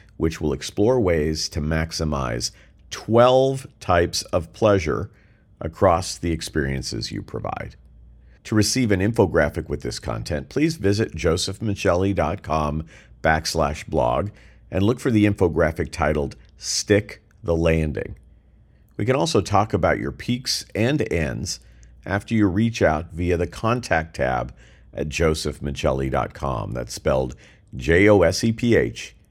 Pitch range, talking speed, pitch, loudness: 75-105 Hz, 115 wpm, 85 Hz, -22 LUFS